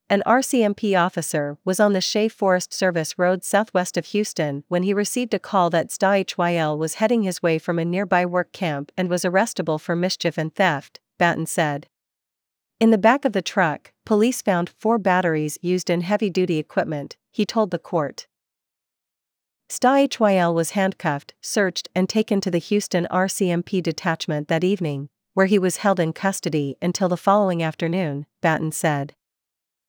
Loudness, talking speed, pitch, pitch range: -21 LUFS, 170 wpm, 180 Hz, 165-200 Hz